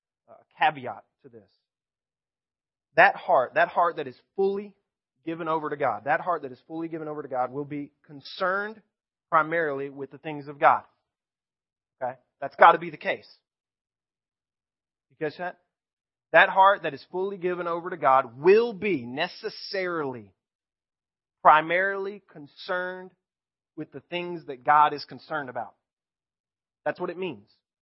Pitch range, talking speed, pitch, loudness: 140-180 Hz, 150 wpm, 155 Hz, -25 LUFS